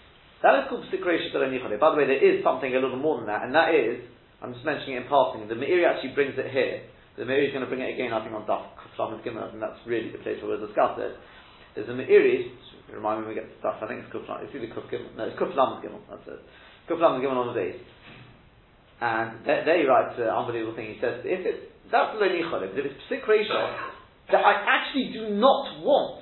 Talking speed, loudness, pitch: 230 wpm, -26 LUFS, 260 Hz